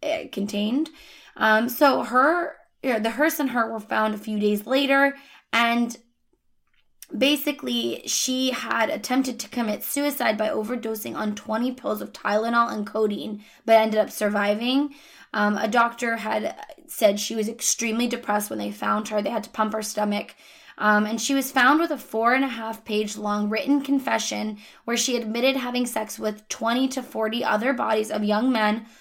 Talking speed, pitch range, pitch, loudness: 175 wpm, 215-265 Hz, 230 Hz, -24 LUFS